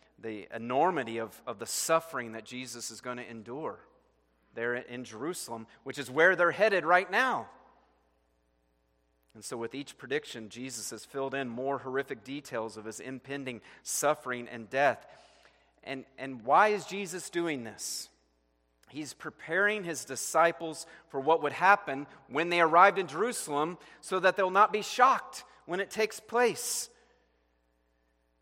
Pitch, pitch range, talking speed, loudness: 135 Hz, 110-170 Hz, 150 wpm, -30 LUFS